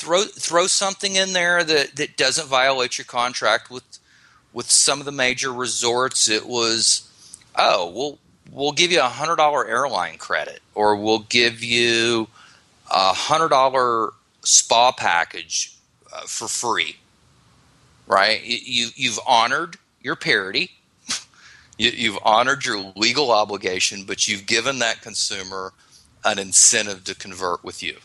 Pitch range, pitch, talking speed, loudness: 110-135 Hz, 120 Hz, 135 wpm, -19 LUFS